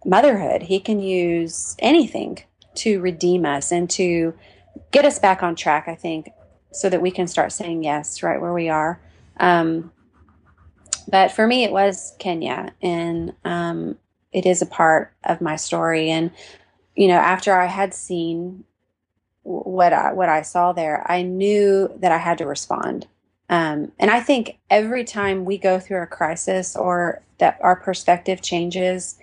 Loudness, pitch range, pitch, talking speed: -20 LUFS, 165-190 Hz, 180 Hz, 165 wpm